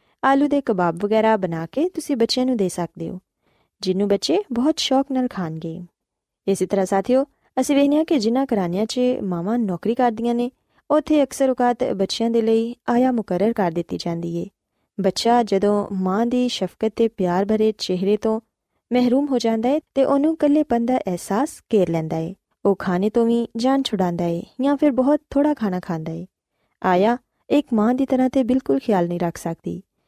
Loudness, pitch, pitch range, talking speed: -21 LUFS, 225 Hz, 185-255 Hz, 180 wpm